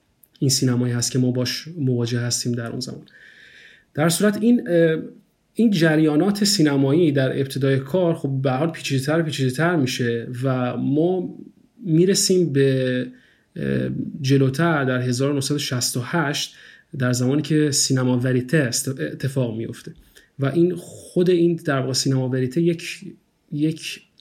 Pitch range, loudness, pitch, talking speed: 130-170 Hz, -21 LUFS, 140 Hz, 125 wpm